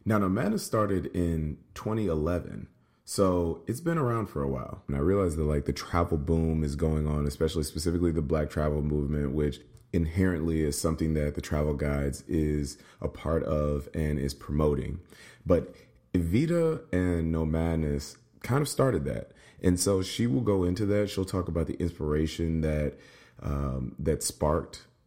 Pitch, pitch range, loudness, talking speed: 80 Hz, 75-90 Hz, -29 LUFS, 165 wpm